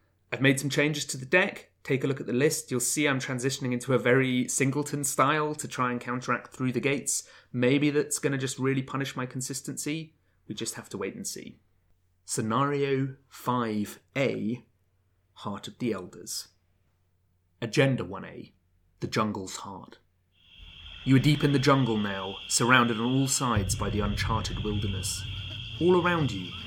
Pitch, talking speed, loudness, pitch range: 120 Hz, 165 wpm, -28 LUFS, 100-135 Hz